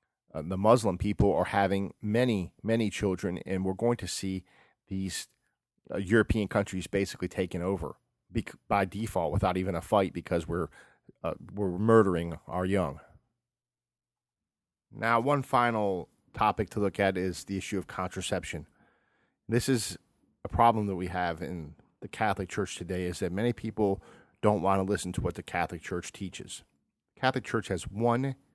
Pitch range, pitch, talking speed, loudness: 90-110 Hz, 100 Hz, 160 wpm, -30 LUFS